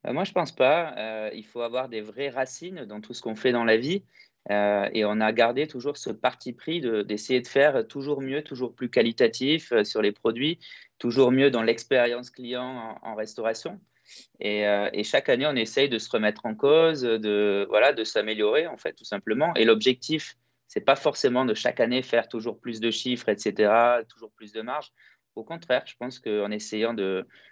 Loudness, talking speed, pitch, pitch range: -25 LUFS, 205 wpm, 115 Hz, 110-130 Hz